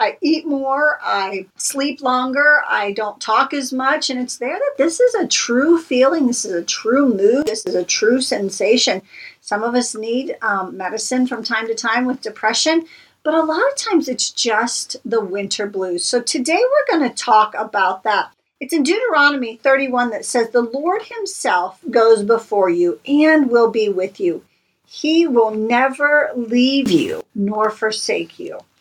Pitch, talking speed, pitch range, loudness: 255 Hz, 175 wpm, 220-295 Hz, -17 LUFS